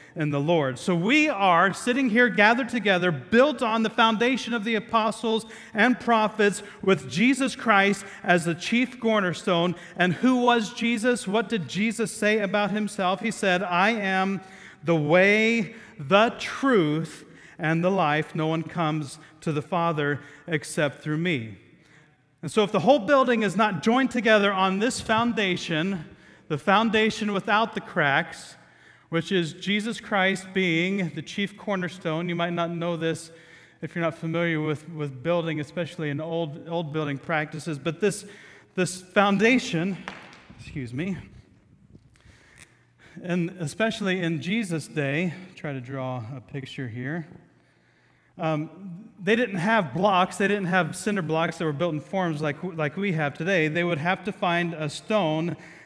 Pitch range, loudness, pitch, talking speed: 160-210 Hz, -24 LUFS, 180 Hz, 155 wpm